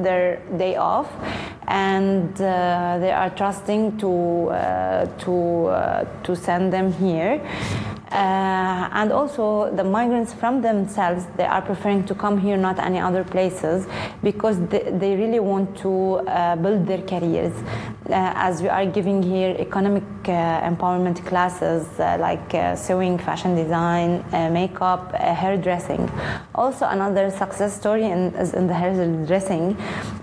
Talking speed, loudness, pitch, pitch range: 145 wpm, -22 LUFS, 185 Hz, 175-195 Hz